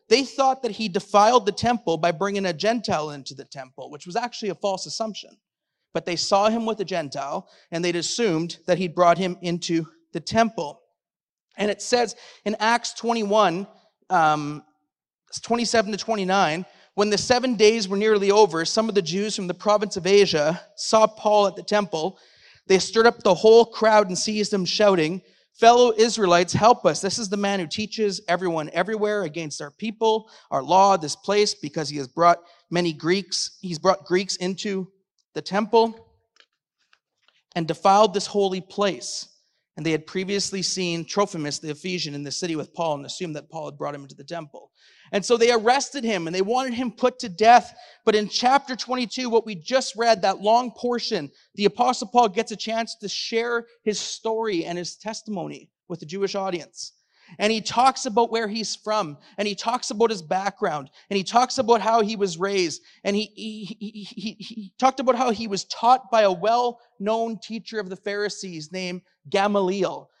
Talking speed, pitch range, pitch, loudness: 190 wpm, 175-225 Hz, 205 Hz, -22 LUFS